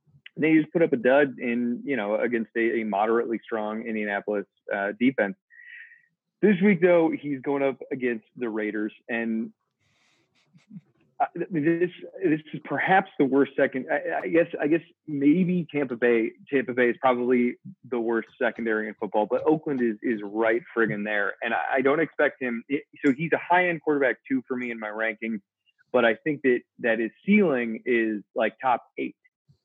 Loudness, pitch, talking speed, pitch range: -25 LUFS, 130 Hz, 180 wpm, 115-160 Hz